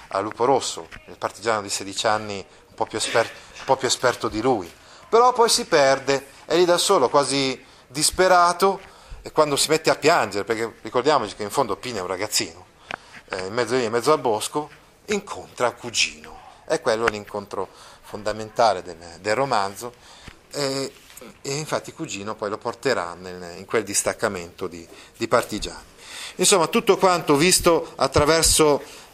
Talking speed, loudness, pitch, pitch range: 160 wpm, -21 LUFS, 130 Hz, 105-155 Hz